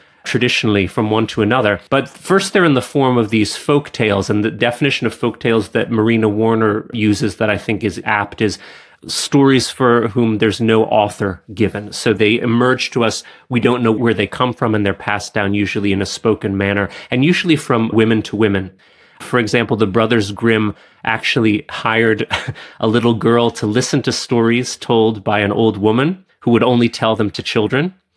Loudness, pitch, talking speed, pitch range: -16 LUFS, 115 Hz, 195 wpm, 105-120 Hz